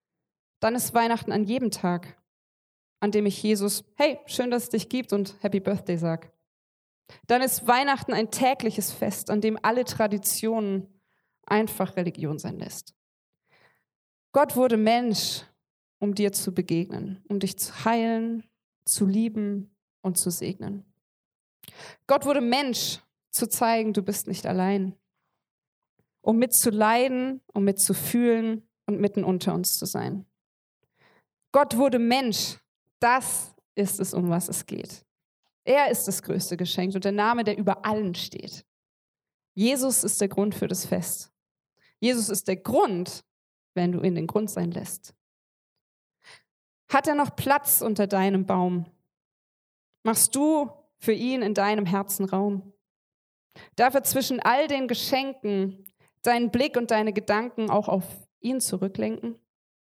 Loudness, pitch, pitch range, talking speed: -25 LUFS, 205 Hz, 190-235 Hz, 140 wpm